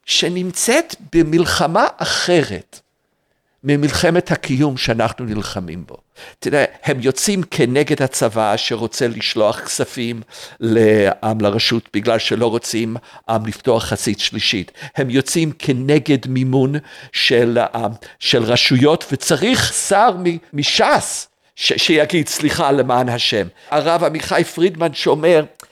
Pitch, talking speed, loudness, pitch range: 135 Hz, 105 wpm, -16 LUFS, 115-160 Hz